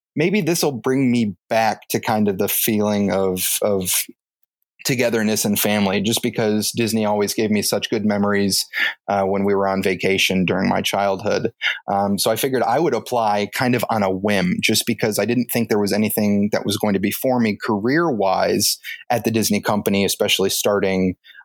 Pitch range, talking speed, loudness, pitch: 100-115 Hz, 195 wpm, -19 LUFS, 105 Hz